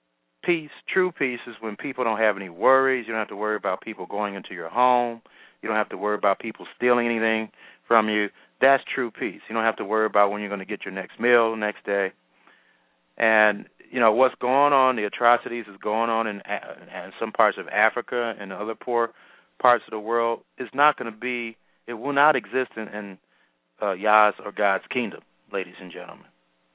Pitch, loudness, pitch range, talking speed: 110 Hz, -24 LUFS, 105-120 Hz, 215 wpm